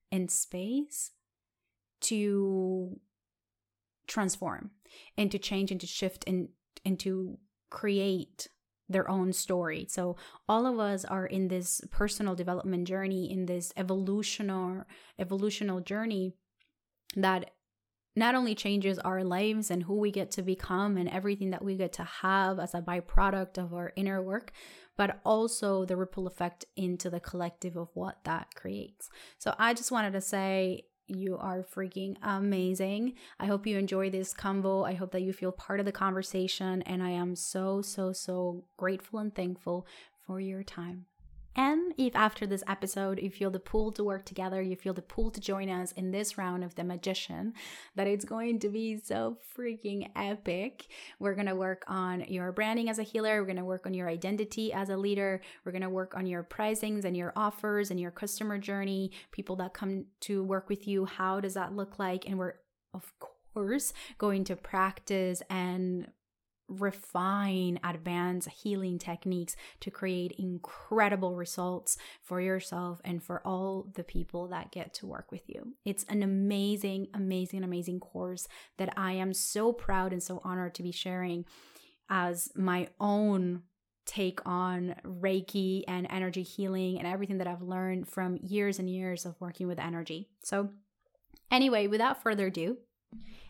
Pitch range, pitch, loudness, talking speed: 180-200 Hz, 190 Hz, -33 LUFS, 165 wpm